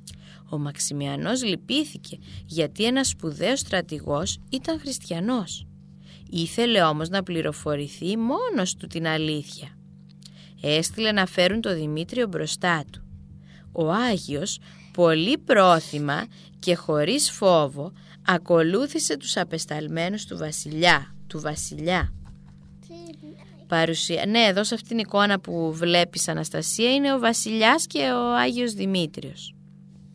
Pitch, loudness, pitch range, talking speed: 175 Hz, -24 LUFS, 155-215 Hz, 110 wpm